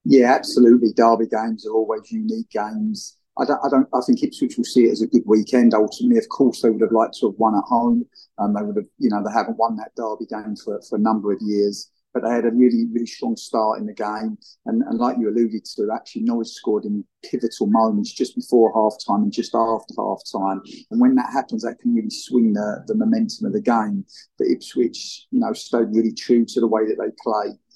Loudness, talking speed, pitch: -20 LUFS, 240 wpm, 115 Hz